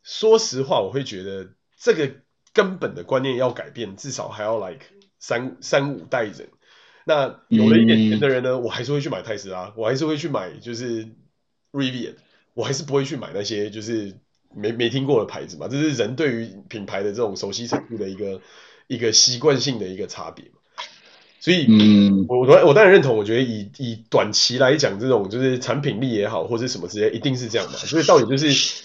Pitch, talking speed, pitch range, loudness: 120 Hz, 320 characters per minute, 110-140 Hz, -20 LUFS